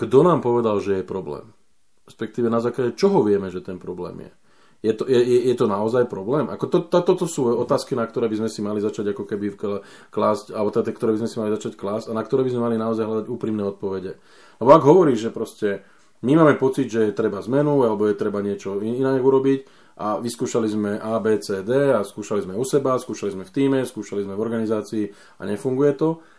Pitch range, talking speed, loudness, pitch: 105-135 Hz, 230 wpm, -21 LUFS, 110 Hz